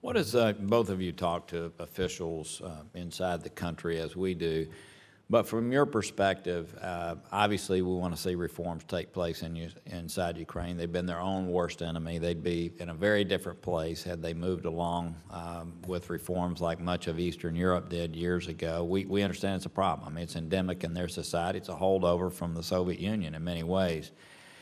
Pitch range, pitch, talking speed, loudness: 85-95 Hz, 85 Hz, 200 wpm, -32 LUFS